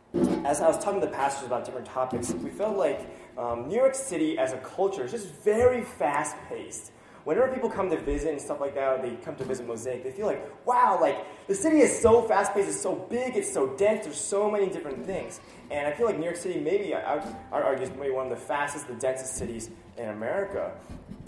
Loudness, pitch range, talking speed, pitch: -28 LUFS, 130-210 Hz, 230 wpm, 160 Hz